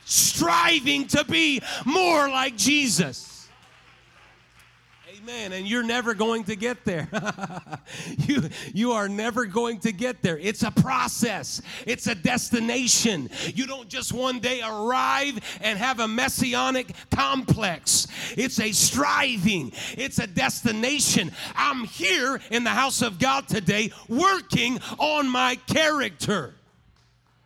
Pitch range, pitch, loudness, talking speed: 210-260 Hz, 235 Hz, -23 LUFS, 125 wpm